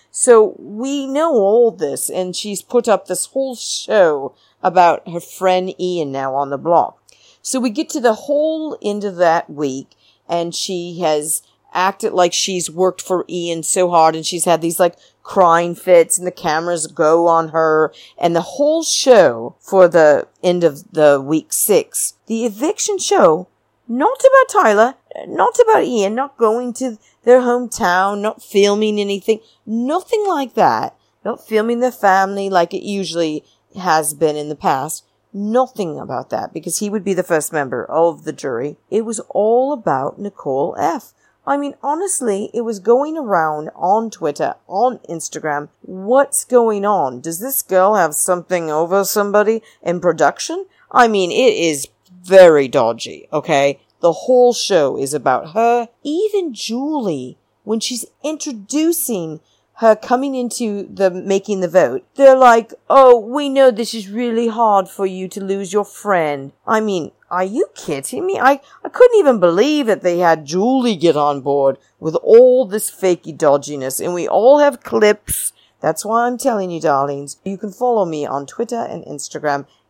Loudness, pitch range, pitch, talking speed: -16 LUFS, 170-250 Hz, 200 Hz, 165 wpm